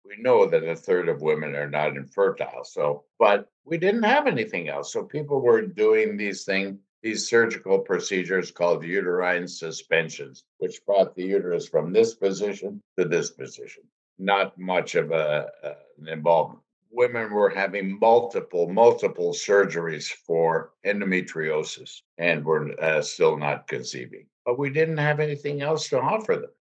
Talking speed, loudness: 155 wpm, -24 LUFS